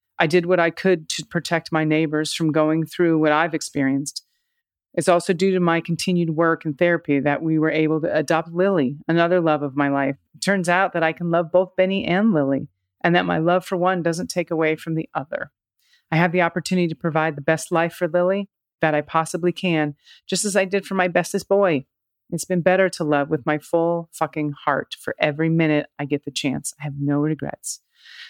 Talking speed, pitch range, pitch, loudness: 220 wpm, 155-180 Hz, 165 Hz, -21 LUFS